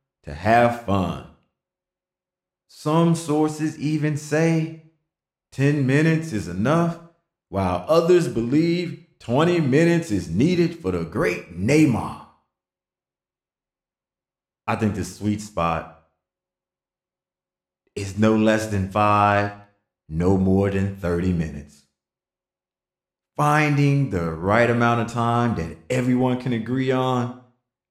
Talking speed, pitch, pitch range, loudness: 105 wpm, 120 Hz, 95-155 Hz, -21 LUFS